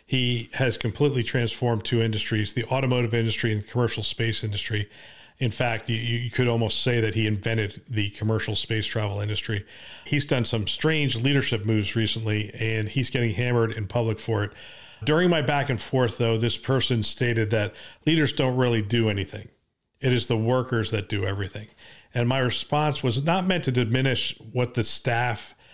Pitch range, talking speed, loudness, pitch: 110-125 Hz, 180 wpm, -25 LUFS, 115 Hz